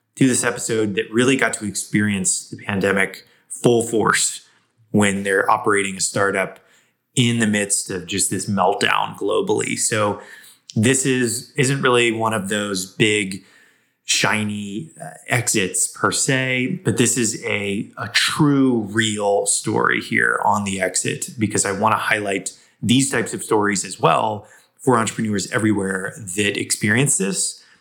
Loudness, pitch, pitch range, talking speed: -19 LUFS, 110 Hz, 100-125 Hz, 145 wpm